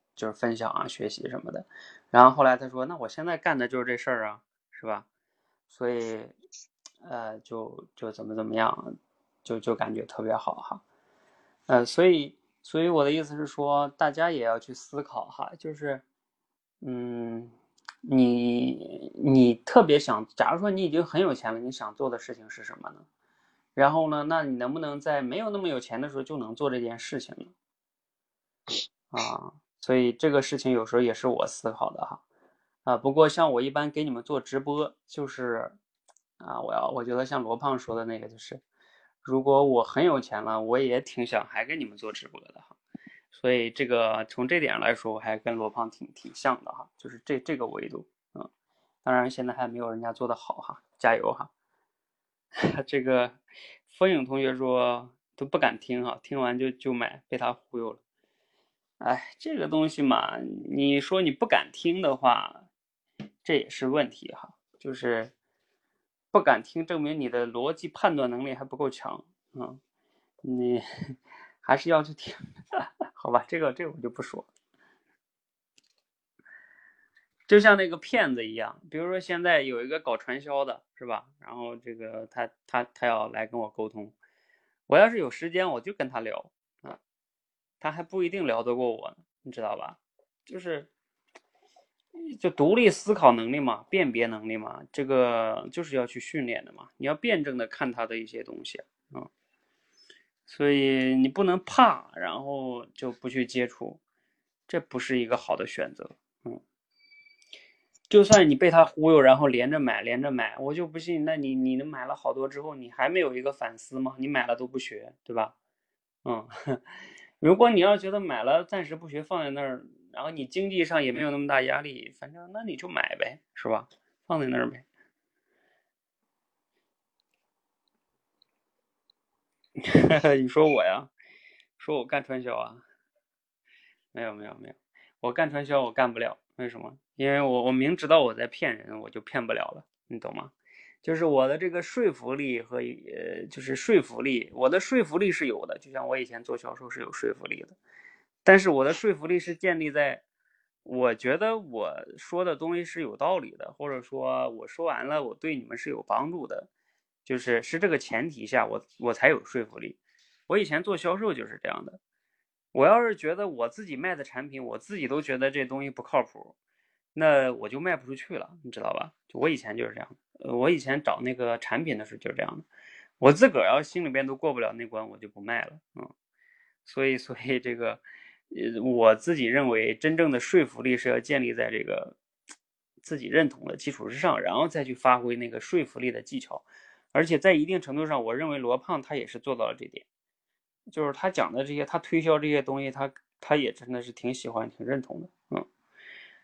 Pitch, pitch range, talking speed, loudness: 135 Hz, 120-165 Hz, 260 characters per minute, -27 LUFS